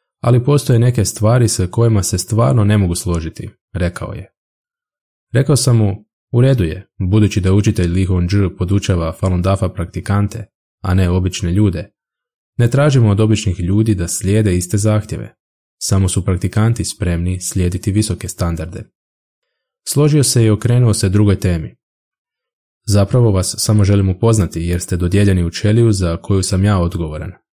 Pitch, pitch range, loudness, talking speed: 100 Hz, 90-110 Hz, -15 LUFS, 150 wpm